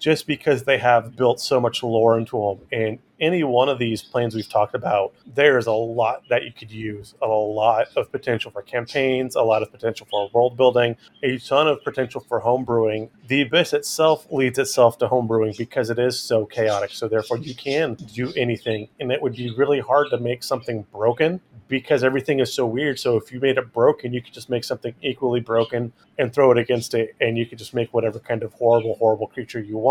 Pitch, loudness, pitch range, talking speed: 120 Hz, -21 LUFS, 115-130 Hz, 220 wpm